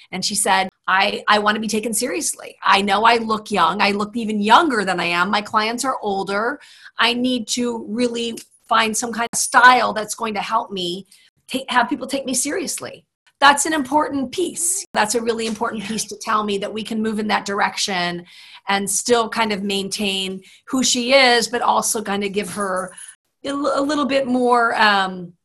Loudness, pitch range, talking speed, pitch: -19 LUFS, 200-245 Hz, 200 wpm, 220 Hz